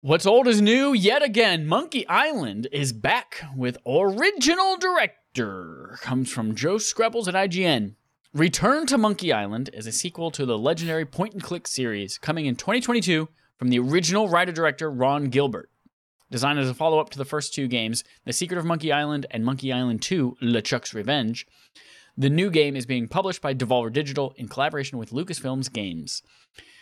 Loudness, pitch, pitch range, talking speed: -23 LUFS, 145 Hz, 125-175 Hz, 170 wpm